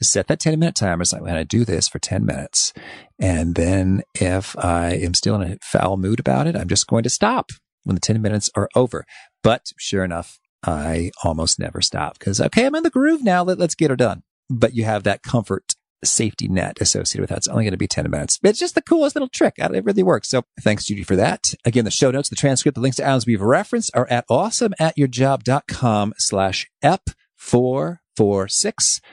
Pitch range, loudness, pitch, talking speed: 95-150 Hz, -19 LUFS, 115 Hz, 220 wpm